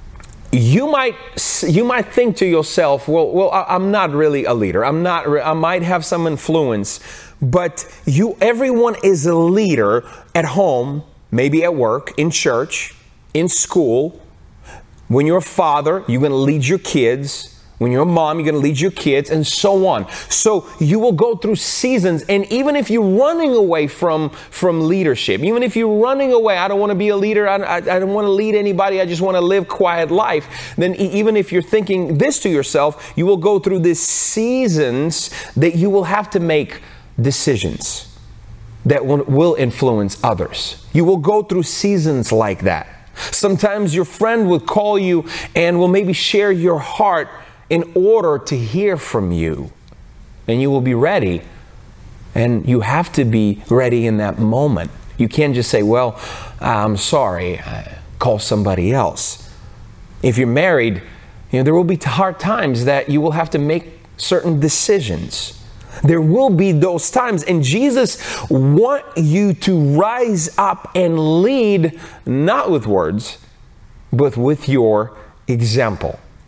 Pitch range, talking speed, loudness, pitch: 130-195 Hz, 170 wpm, -16 LUFS, 165 Hz